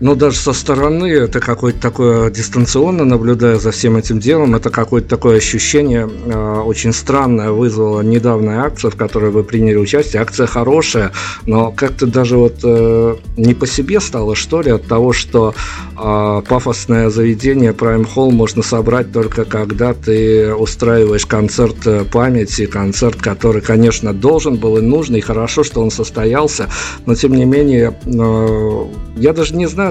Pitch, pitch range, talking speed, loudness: 115 Hz, 110-125 Hz, 155 wpm, -13 LUFS